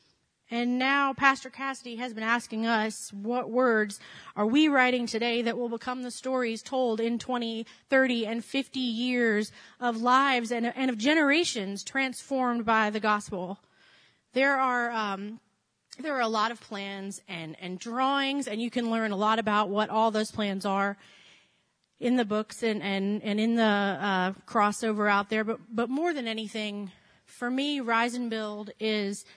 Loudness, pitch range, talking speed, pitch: -28 LUFS, 210-250 Hz, 170 wpm, 230 Hz